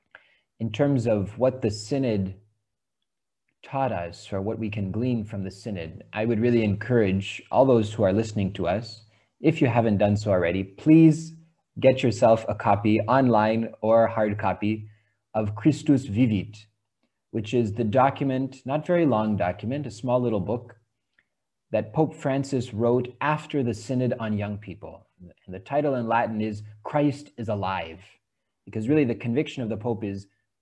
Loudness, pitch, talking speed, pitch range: -25 LUFS, 110 Hz, 165 wpm, 105-130 Hz